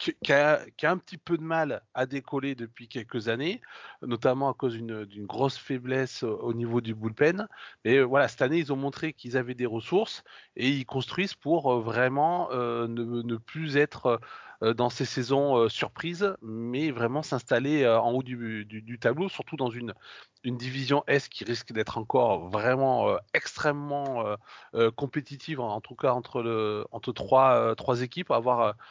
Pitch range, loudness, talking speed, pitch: 115-145 Hz, -28 LUFS, 185 wpm, 130 Hz